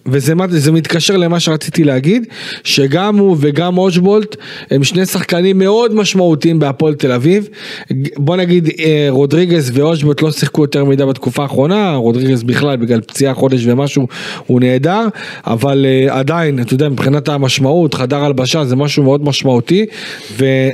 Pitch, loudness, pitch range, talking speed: 150 Hz, -12 LUFS, 135-175 Hz, 140 wpm